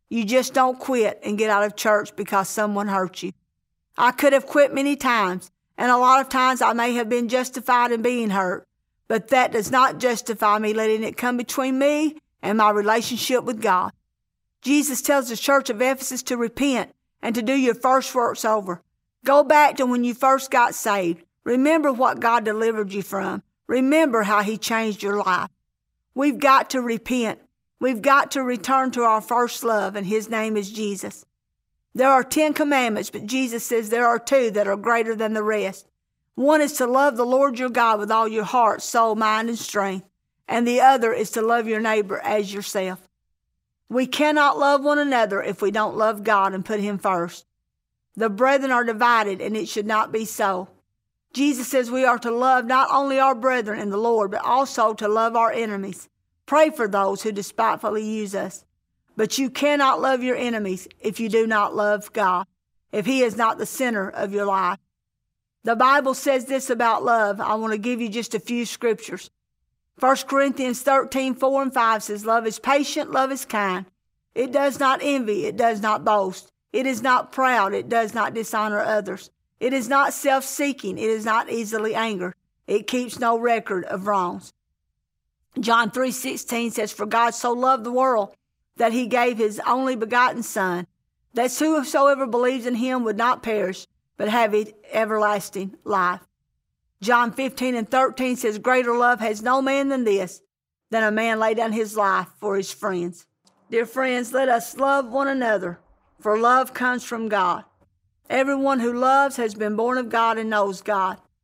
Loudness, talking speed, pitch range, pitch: -21 LUFS, 185 wpm, 210-260 Hz, 230 Hz